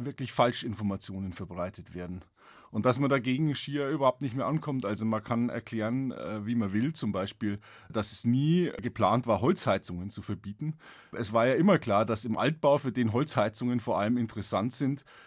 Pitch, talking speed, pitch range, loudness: 120 Hz, 175 wpm, 105-135 Hz, -30 LUFS